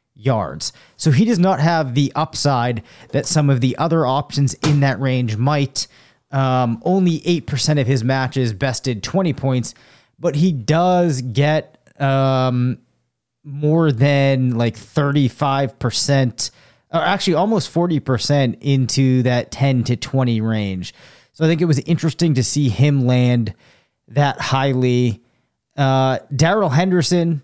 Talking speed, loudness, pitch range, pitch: 135 wpm, -18 LUFS, 125-155 Hz, 135 Hz